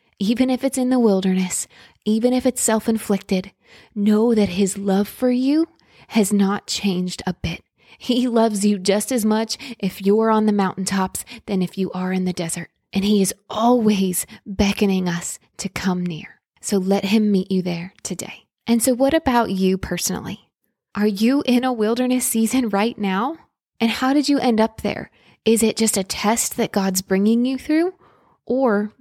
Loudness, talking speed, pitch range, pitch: -20 LUFS, 180 wpm, 195-240 Hz, 210 Hz